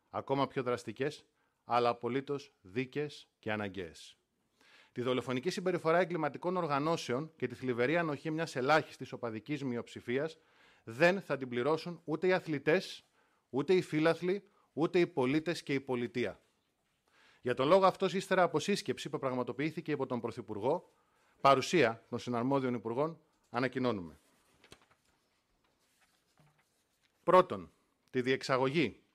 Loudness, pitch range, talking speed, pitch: -33 LUFS, 125-165 Hz, 115 wpm, 135 Hz